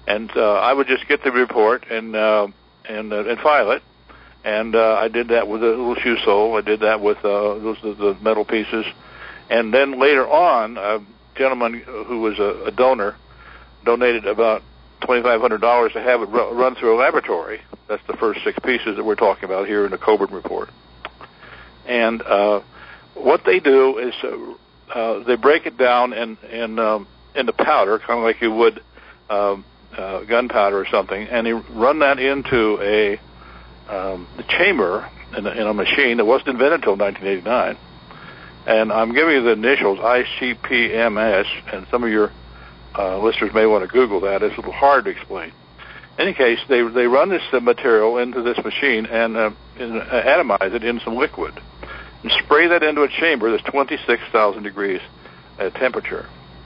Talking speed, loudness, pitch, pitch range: 185 wpm, -18 LUFS, 115 Hz, 105-130 Hz